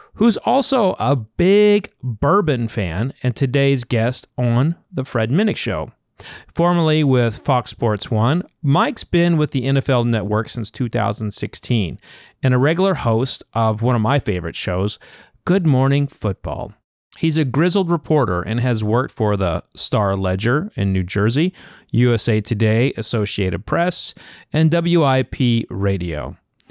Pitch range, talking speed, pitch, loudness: 110-155 Hz, 135 wpm, 125 Hz, -18 LUFS